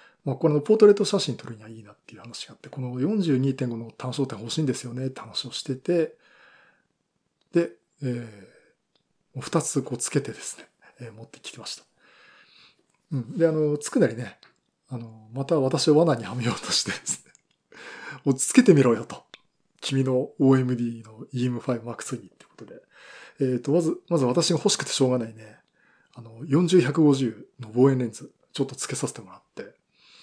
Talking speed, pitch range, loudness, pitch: 325 characters per minute, 120-165 Hz, -24 LUFS, 135 Hz